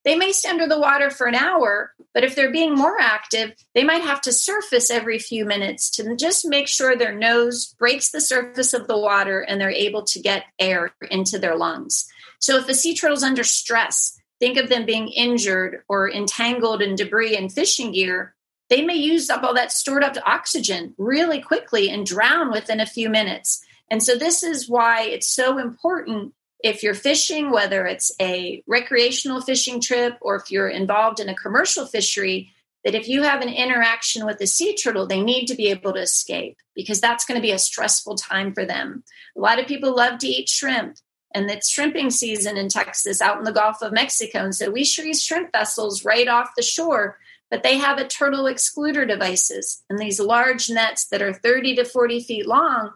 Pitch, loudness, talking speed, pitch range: 240 Hz, -20 LUFS, 205 wpm, 210-275 Hz